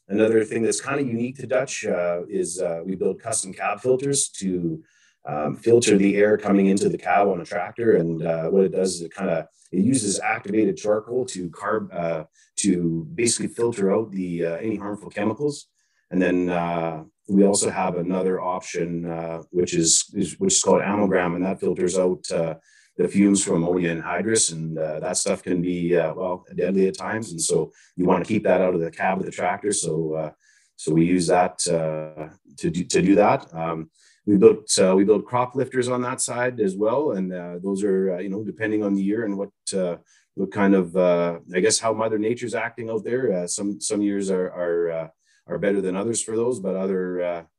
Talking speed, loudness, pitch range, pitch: 215 wpm, -23 LUFS, 85-105 Hz, 95 Hz